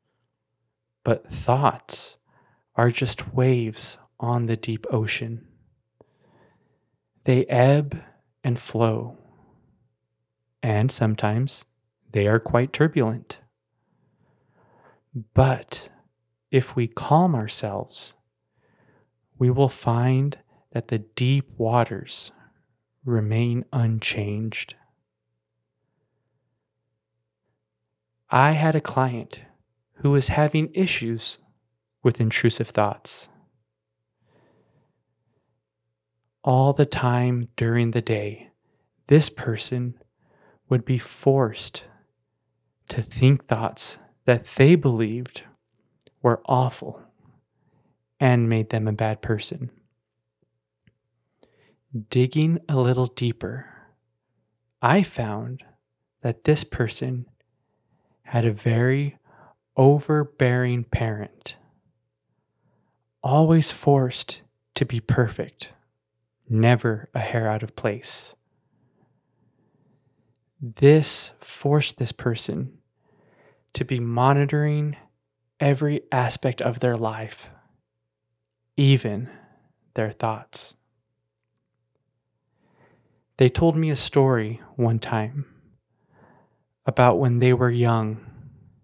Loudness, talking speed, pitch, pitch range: -23 LUFS, 80 wpm, 120 Hz, 110-130 Hz